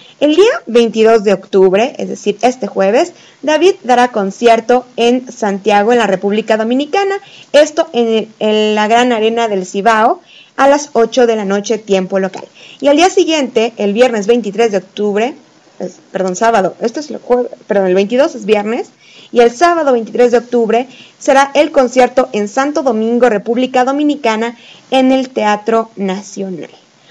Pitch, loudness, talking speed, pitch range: 235 Hz, -12 LUFS, 165 wpm, 210-260 Hz